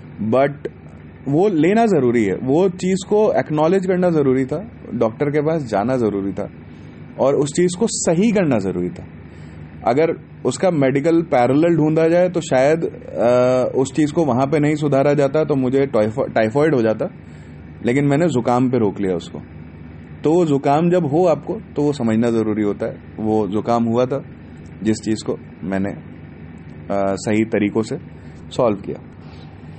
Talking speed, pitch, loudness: 165 wpm, 120 Hz, -18 LUFS